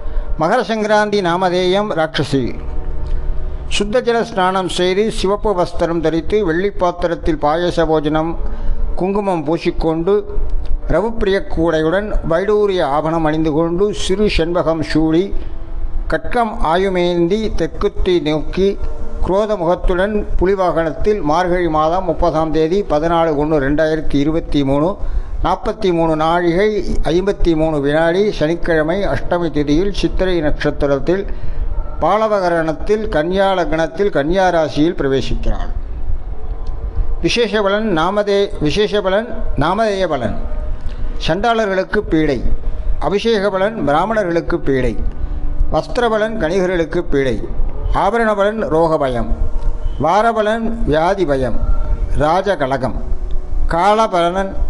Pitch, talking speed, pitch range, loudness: 170 Hz, 85 wpm, 150-200 Hz, -17 LUFS